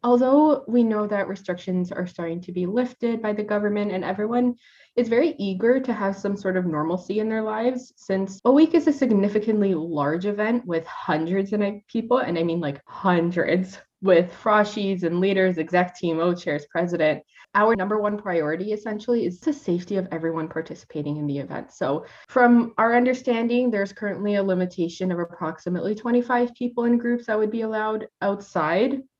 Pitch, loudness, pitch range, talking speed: 200 Hz, -23 LUFS, 175-235 Hz, 175 wpm